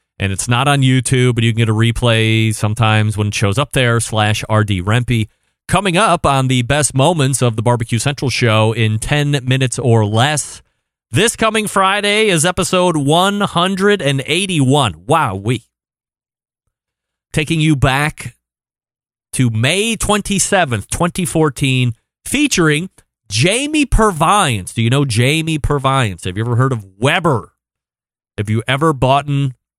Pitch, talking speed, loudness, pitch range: 130 Hz, 145 wpm, -14 LUFS, 115-160 Hz